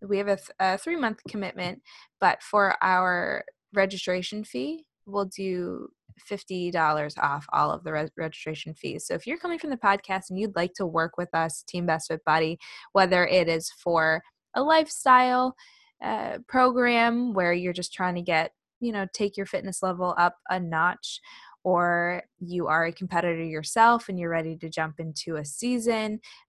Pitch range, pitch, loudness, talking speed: 170-220 Hz, 185 Hz, -26 LUFS, 175 wpm